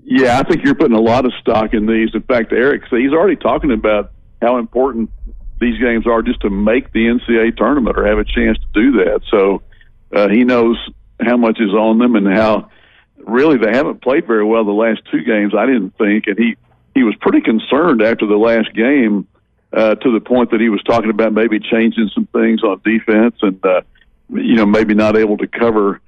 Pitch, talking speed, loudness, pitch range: 110 Hz, 215 wpm, -14 LUFS, 105-115 Hz